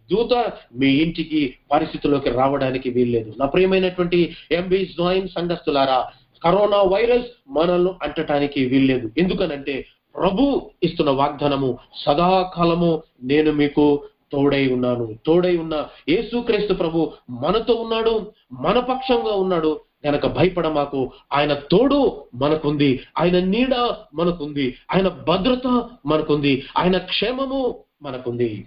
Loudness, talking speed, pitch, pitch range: -20 LUFS, 105 wpm, 160 Hz, 140-190 Hz